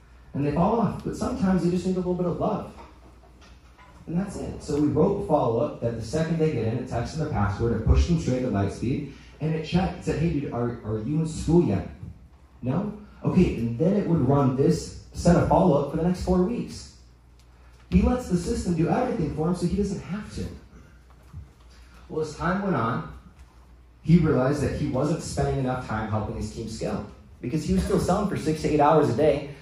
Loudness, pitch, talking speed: -25 LUFS, 145 Hz, 225 wpm